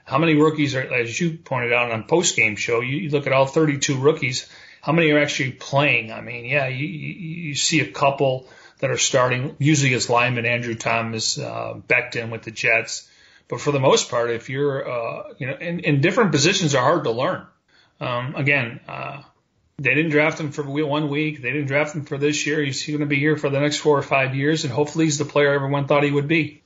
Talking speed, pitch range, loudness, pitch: 230 wpm, 130-150 Hz, -20 LUFS, 145 Hz